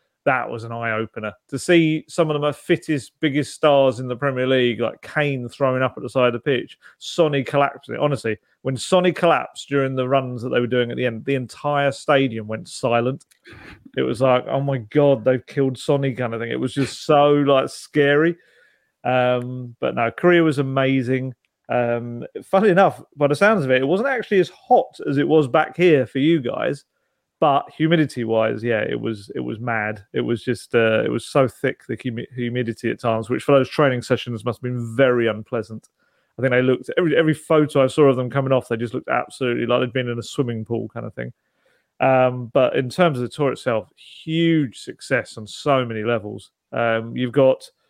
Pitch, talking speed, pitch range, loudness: 130 Hz, 210 wpm, 120-145 Hz, -20 LUFS